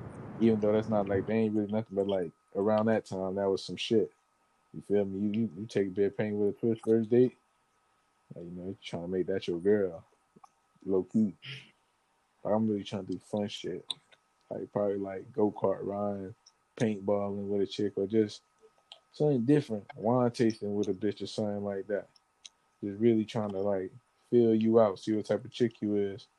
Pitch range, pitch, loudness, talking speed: 100-115 Hz, 105 Hz, -31 LUFS, 205 wpm